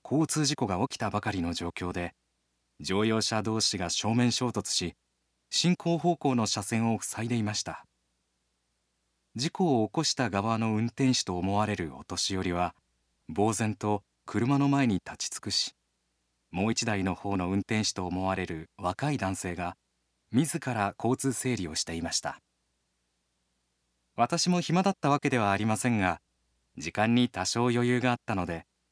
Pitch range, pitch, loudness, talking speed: 80-120 Hz, 100 Hz, -29 LUFS, 295 characters per minute